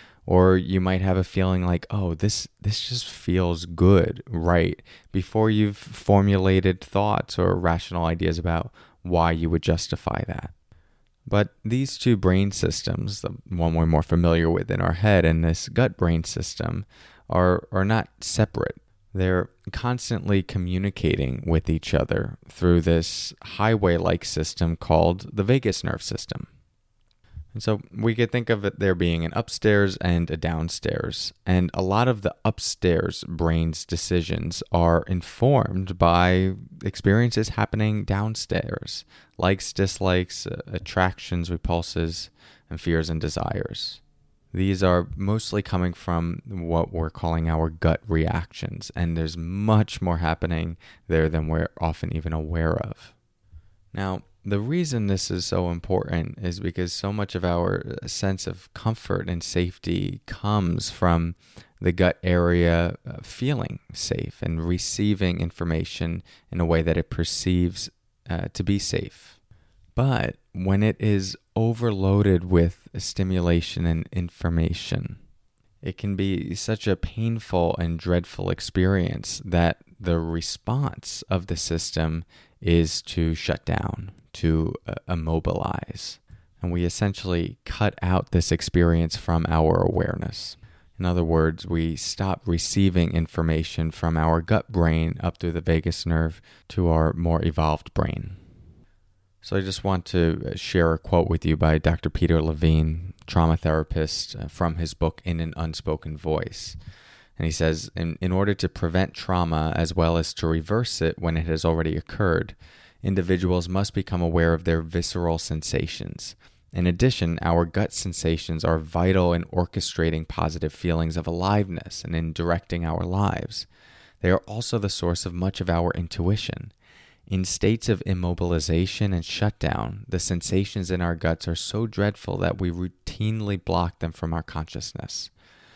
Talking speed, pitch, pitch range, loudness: 145 wpm, 90 Hz, 85-100 Hz, -25 LUFS